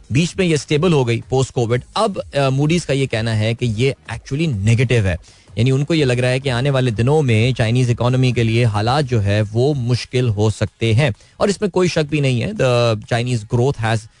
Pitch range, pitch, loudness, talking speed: 115-140 Hz, 125 Hz, -17 LUFS, 220 wpm